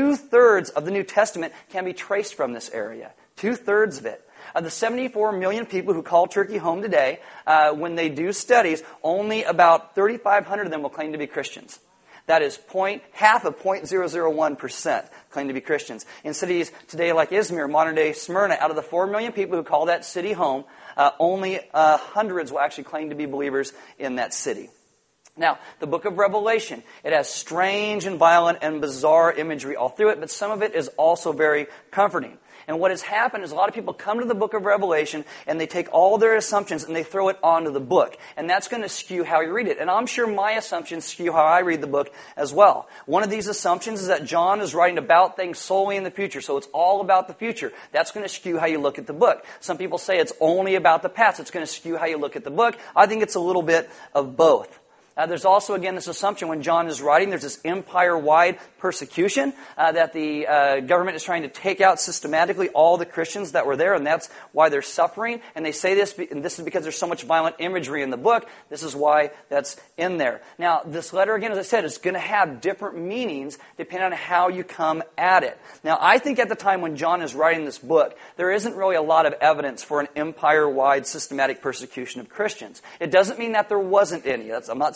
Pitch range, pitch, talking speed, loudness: 155-200 Hz, 175 Hz, 230 wpm, -22 LUFS